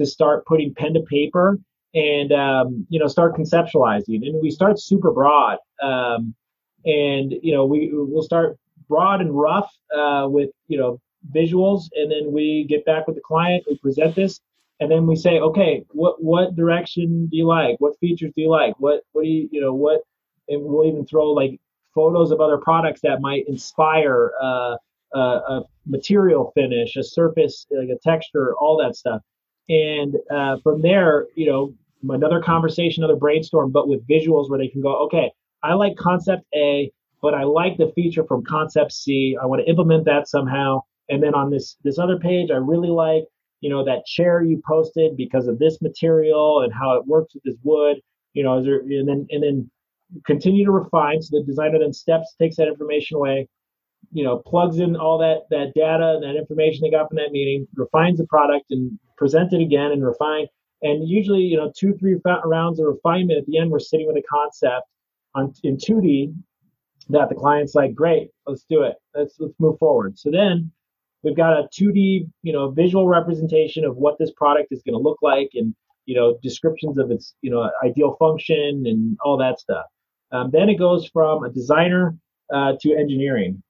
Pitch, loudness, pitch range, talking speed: 155 Hz, -19 LUFS, 140-165 Hz, 195 wpm